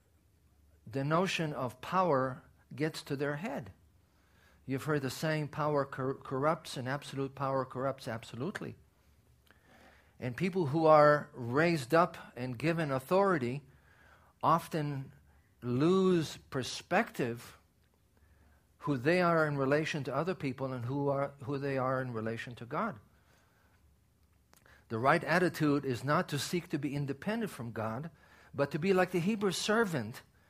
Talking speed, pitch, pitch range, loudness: 135 wpm, 140 Hz, 120-160 Hz, -33 LUFS